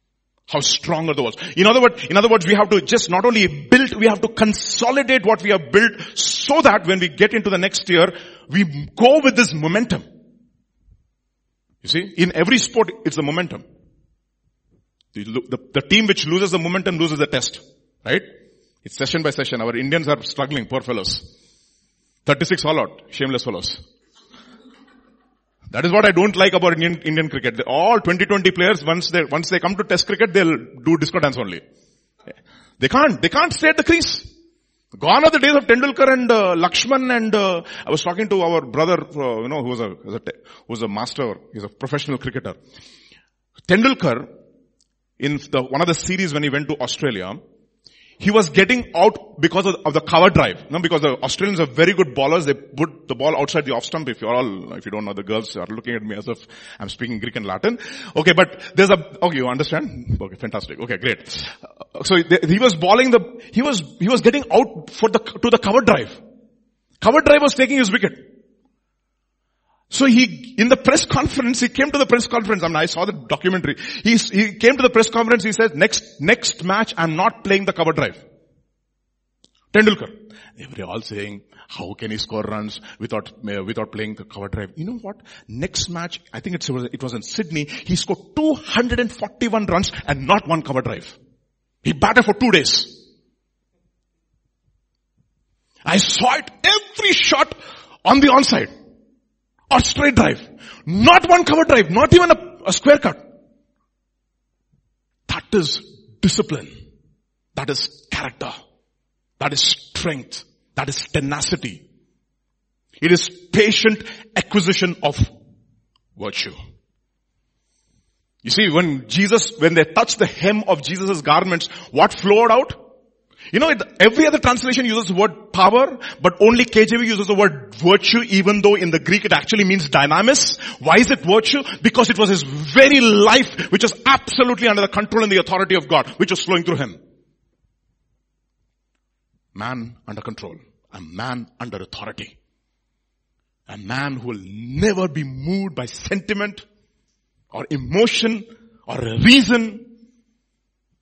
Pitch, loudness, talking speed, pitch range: 190 Hz, -17 LUFS, 175 wpm, 150-230 Hz